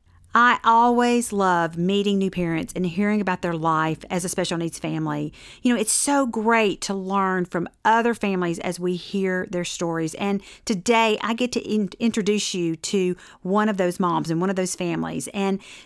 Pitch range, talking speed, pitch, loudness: 175-215 Hz, 190 wpm, 190 Hz, -22 LUFS